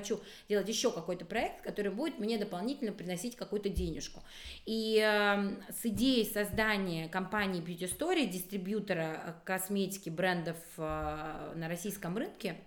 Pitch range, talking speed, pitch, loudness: 180-220 Hz, 130 wpm, 200 Hz, -35 LUFS